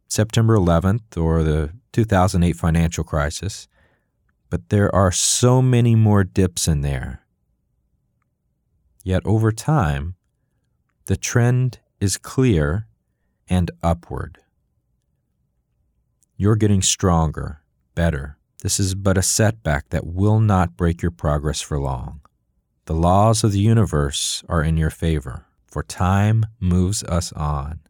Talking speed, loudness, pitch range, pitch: 120 wpm, -19 LUFS, 80-105 Hz, 90 Hz